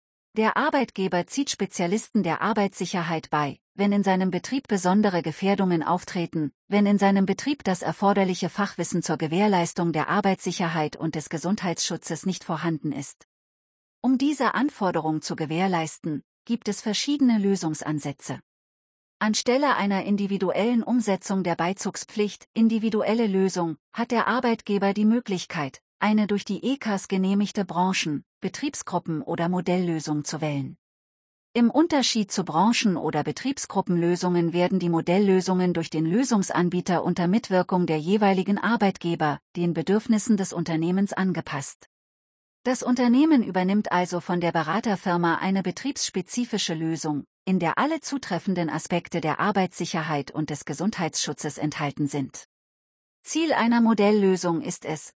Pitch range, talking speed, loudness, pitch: 165-210 Hz, 125 wpm, -25 LUFS, 185 Hz